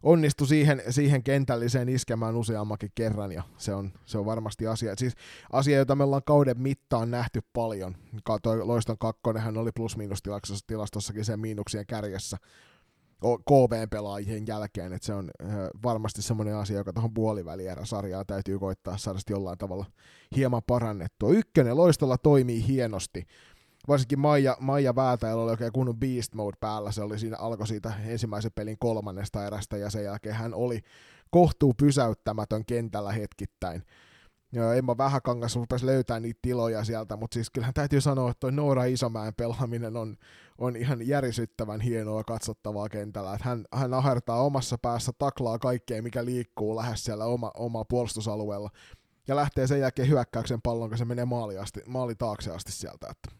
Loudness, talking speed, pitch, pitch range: -29 LUFS, 155 wpm, 115 Hz, 105-125 Hz